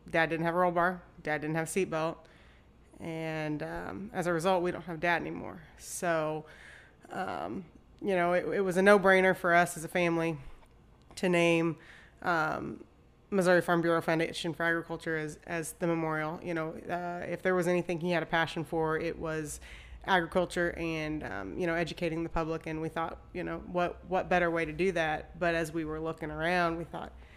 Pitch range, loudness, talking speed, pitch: 160-175 Hz, -31 LUFS, 200 wpm, 165 Hz